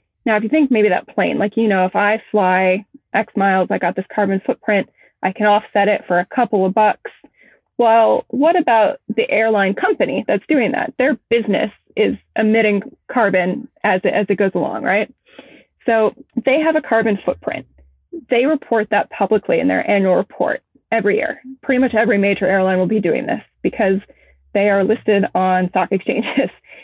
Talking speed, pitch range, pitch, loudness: 185 wpm, 195-245 Hz, 215 Hz, -17 LUFS